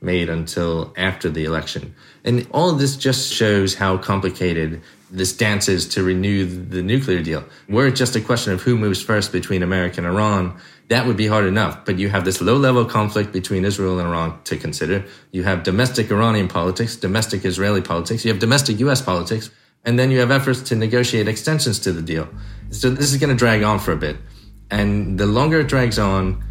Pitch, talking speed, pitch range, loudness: 105 Hz, 210 wpm, 95-120 Hz, -19 LUFS